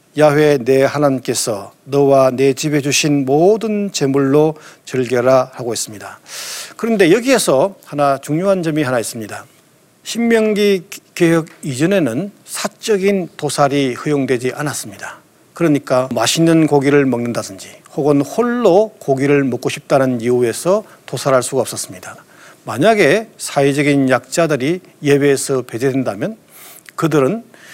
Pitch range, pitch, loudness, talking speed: 135-170 Hz, 145 Hz, -15 LUFS, 295 characters per minute